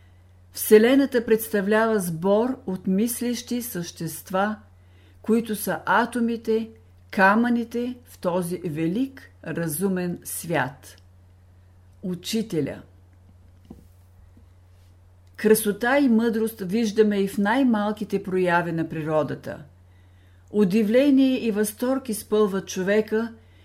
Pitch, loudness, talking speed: 195 Hz, -23 LUFS, 80 wpm